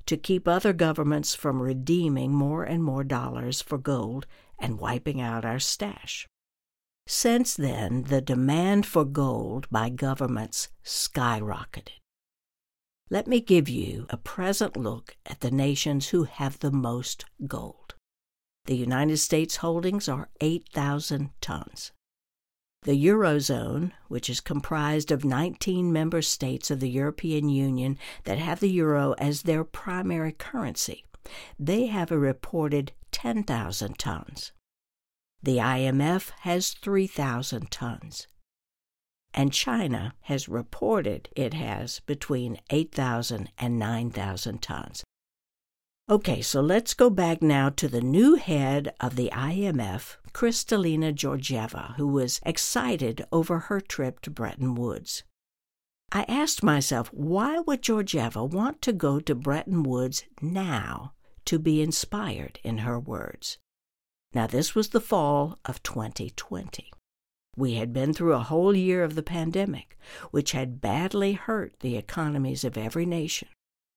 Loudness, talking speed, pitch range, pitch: -27 LUFS, 130 wpm, 130-170 Hz, 145 Hz